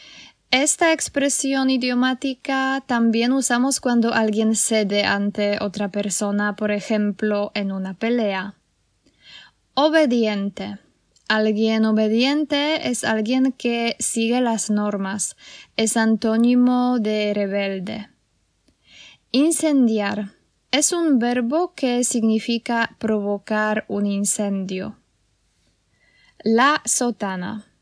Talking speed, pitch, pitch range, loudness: 85 wpm, 225 Hz, 205-255 Hz, -20 LUFS